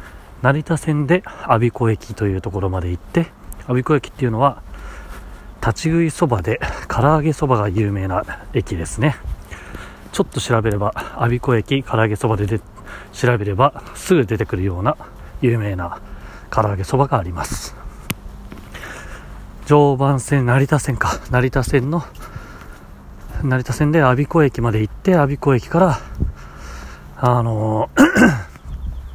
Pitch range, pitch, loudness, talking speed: 100-140 Hz, 115 Hz, -18 LUFS, 260 characters per minute